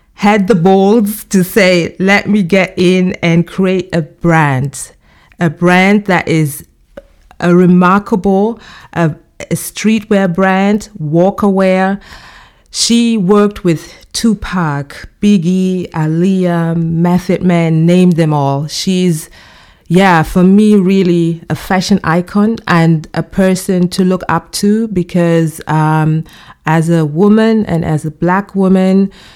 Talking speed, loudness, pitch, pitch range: 125 wpm, -11 LUFS, 180 Hz, 165-195 Hz